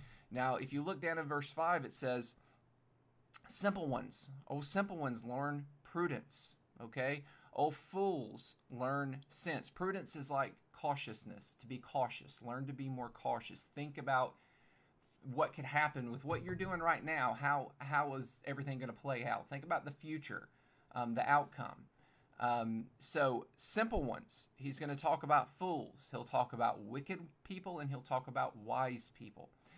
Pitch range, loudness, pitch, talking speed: 130-150 Hz, -40 LUFS, 140 Hz, 165 wpm